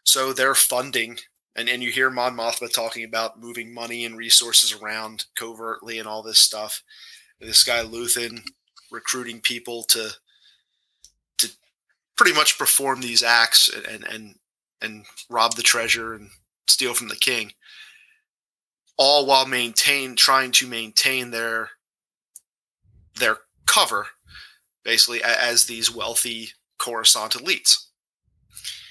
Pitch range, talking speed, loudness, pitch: 115-130 Hz, 125 wpm, -18 LUFS, 120 Hz